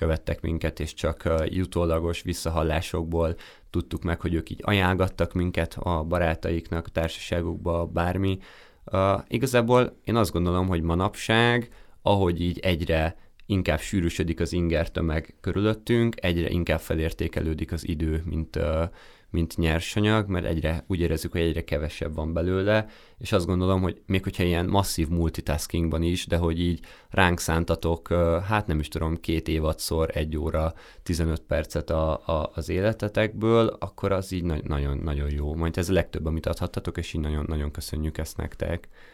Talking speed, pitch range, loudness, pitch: 150 wpm, 80-95 Hz, -26 LUFS, 85 Hz